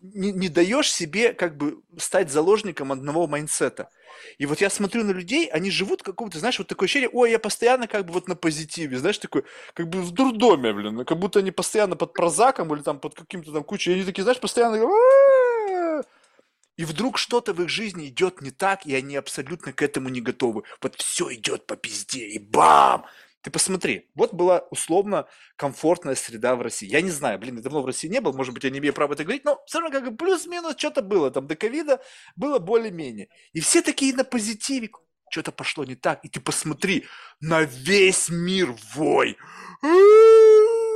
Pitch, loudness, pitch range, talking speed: 185 Hz, -22 LUFS, 155-250 Hz, 195 wpm